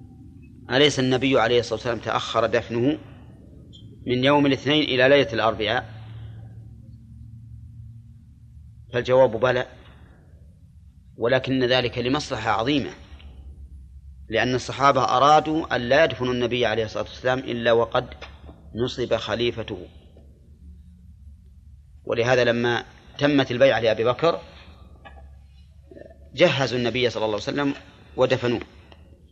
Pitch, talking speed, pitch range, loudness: 115 Hz, 95 wpm, 85-125 Hz, -22 LUFS